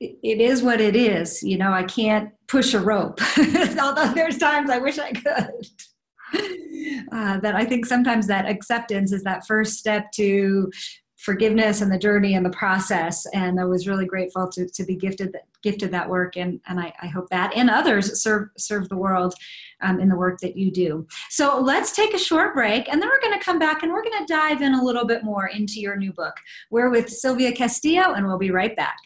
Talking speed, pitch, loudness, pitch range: 215 wpm, 215 Hz, -21 LUFS, 190-270 Hz